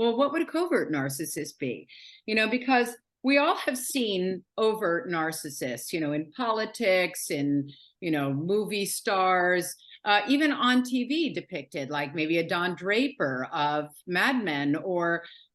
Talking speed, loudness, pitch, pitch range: 150 wpm, -27 LUFS, 185 Hz, 155-250 Hz